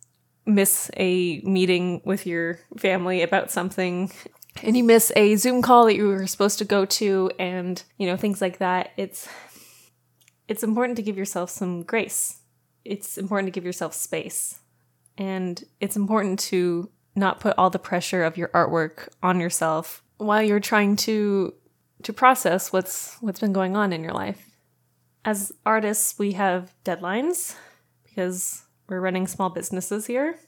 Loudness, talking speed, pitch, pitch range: -23 LUFS, 160 wpm, 190 Hz, 180-210 Hz